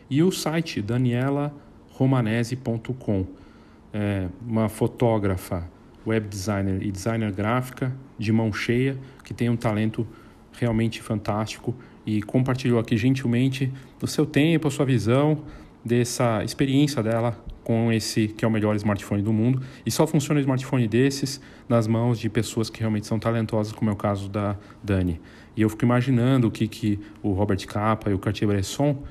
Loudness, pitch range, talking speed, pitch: -24 LUFS, 105-130 Hz, 160 wpm, 115 Hz